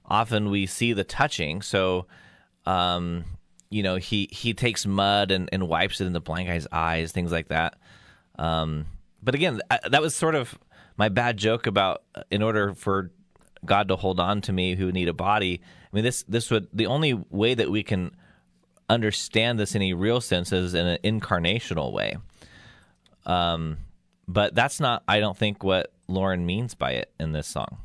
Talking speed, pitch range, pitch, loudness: 185 wpm, 90-110 Hz, 95 Hz, -25 LUFS